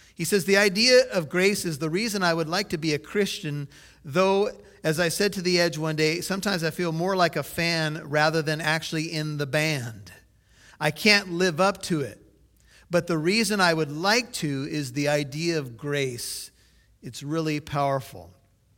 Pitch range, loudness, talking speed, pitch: 145-180 Hz, -24 LUFS, 190 wpm, 160 Hz